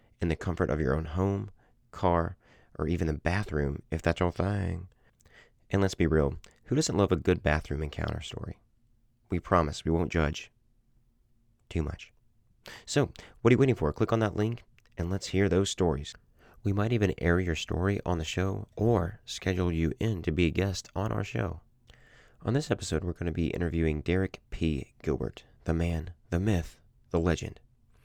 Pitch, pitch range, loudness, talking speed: 95 Hz, 85-110 Hz, -30 LUFS, 185 wpm